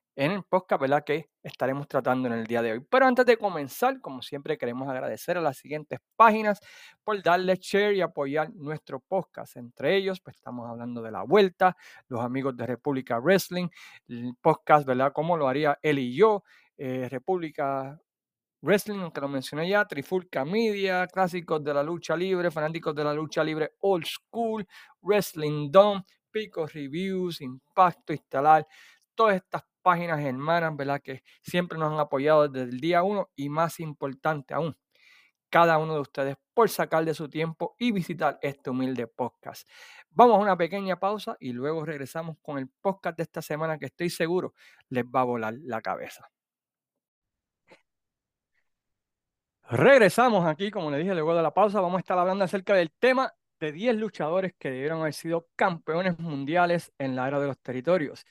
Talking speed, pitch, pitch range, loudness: 170 wpm, 160 Hz, 140-185 Hz, -26 LUFS